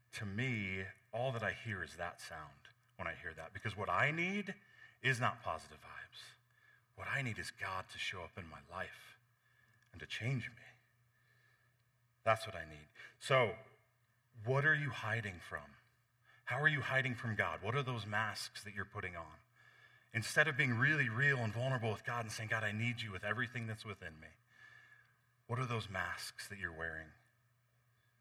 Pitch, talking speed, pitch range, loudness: 115 Hz, 185 wpm, 105-125 Hz, -38 LUFS